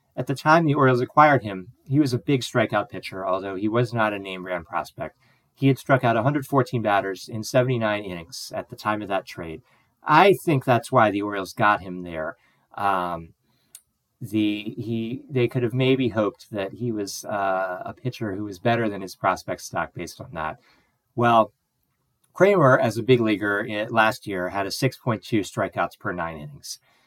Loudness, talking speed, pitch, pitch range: -23 LUFS, 190 wpm, 110 Hz, 100-125 Hz